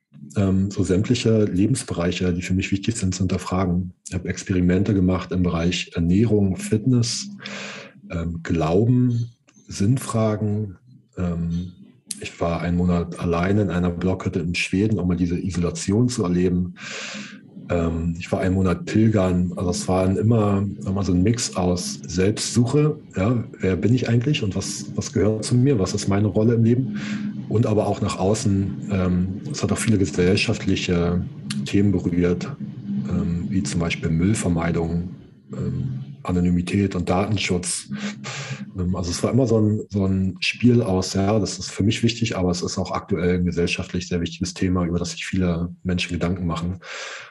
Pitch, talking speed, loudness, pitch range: 95 Hz, 160 wpm, -22 LUFS, 90-105 Hz